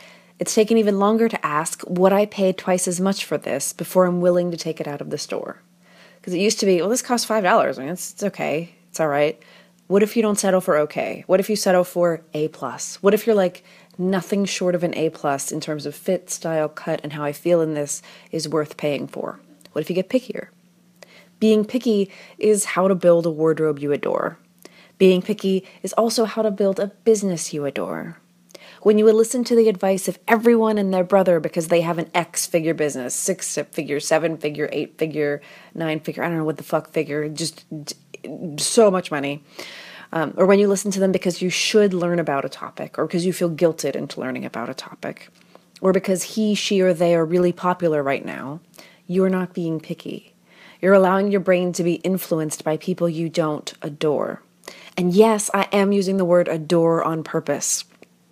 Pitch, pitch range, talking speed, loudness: 180 Hz, 160-195 Hz, 215 wpm, -21 LUFS